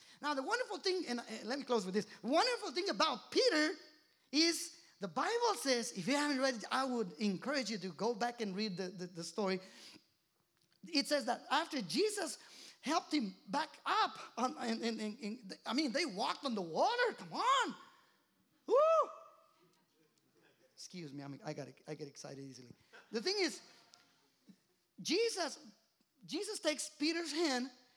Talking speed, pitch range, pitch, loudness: 165 wpm, 210-320 Hz, 260 Hz, -37 LUFS